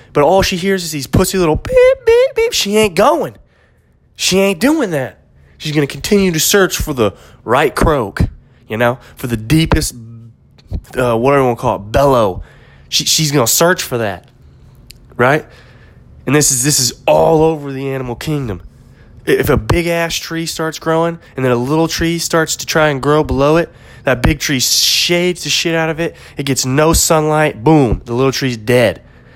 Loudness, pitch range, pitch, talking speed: -13 LUFS, 125-165 Hz, 150 Hz, 195 wpm